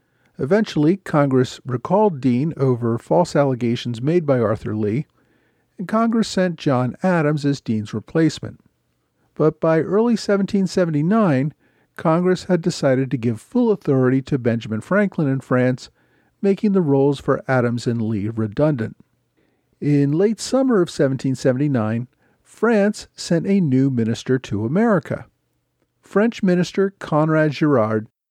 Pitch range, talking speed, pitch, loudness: 125-185 Hz, 125 wpm, 145 Hz, -19 LUFS